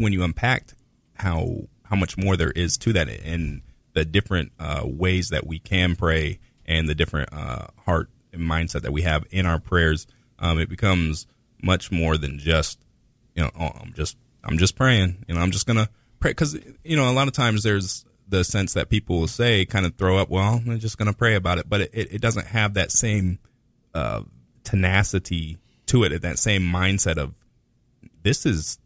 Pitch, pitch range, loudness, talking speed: 95 Hz, 85-110 Hz, -23 LUFS, 200 wpm